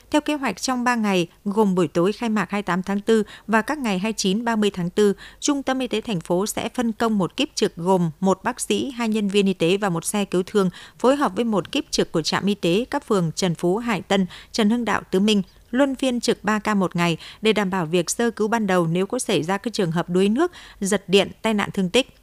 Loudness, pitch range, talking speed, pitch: -22 LUFS, 185-230 Hz, 260 wpm, 205 Hz